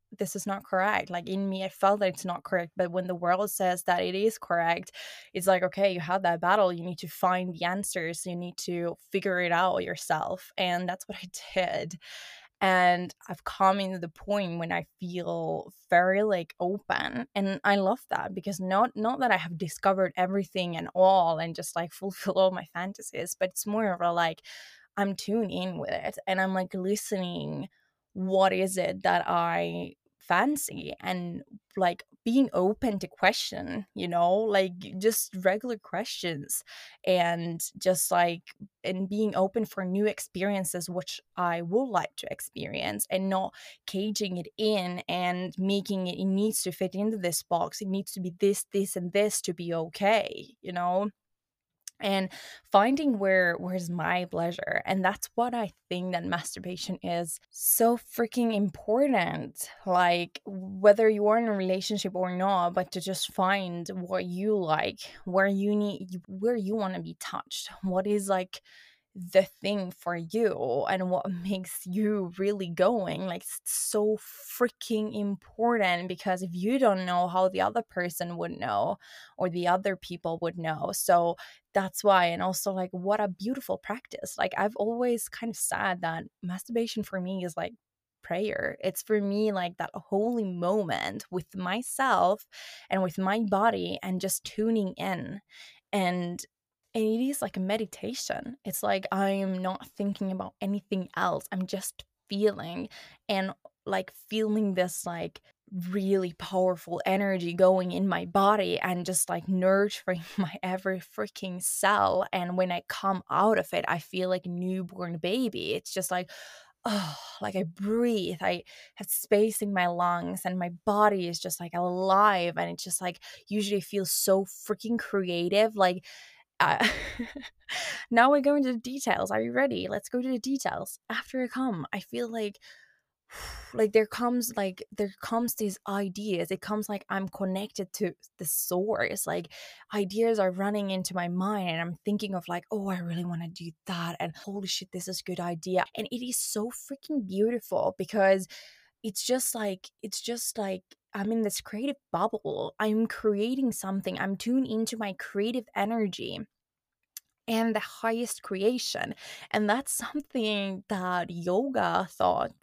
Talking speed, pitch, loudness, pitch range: 170 wpm, 190 Hz, -29 LUFS, 180-210 Hz